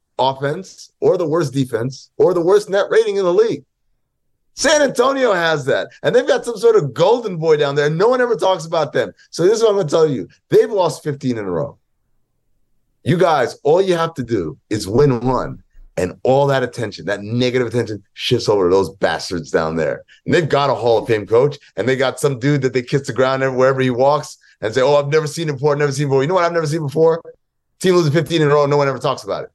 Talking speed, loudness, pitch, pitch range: 260 wpm, -17 LUFS, 145 Hz, 130-175 Hz